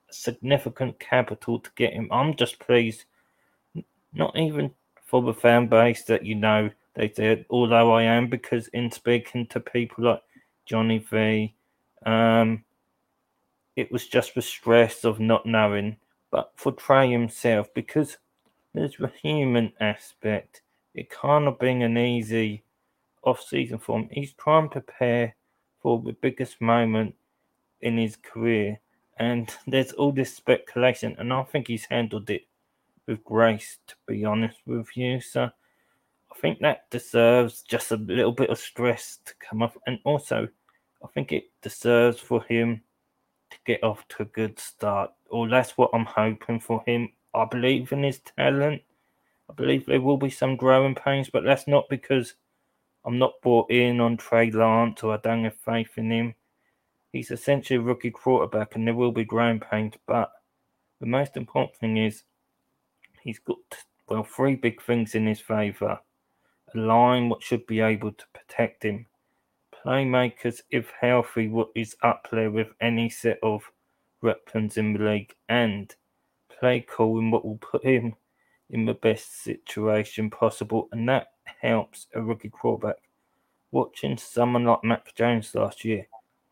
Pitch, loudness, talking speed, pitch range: 115 Hz, -25 LUFS, 160 wpm, 110-125 Hz